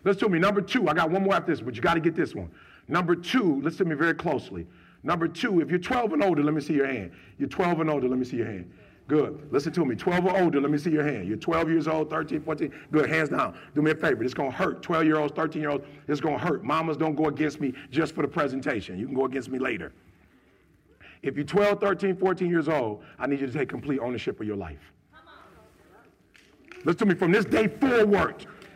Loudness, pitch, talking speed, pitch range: -26 LUFS, 155 Hz, 265 wpm, 140-180 Hz